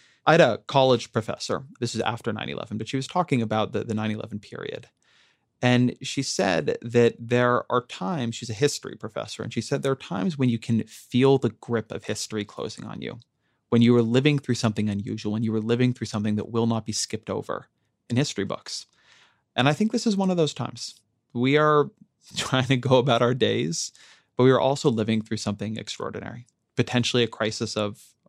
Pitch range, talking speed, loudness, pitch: 110-130 Hz, 210 wpm, -25 LUFS, 120 Hz